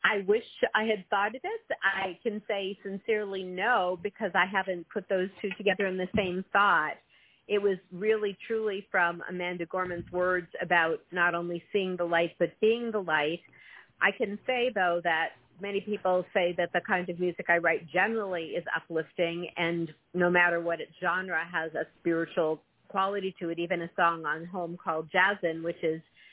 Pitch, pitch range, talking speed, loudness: 180 Hz, 170-200 Hz, 180 wpm, -29 LUFS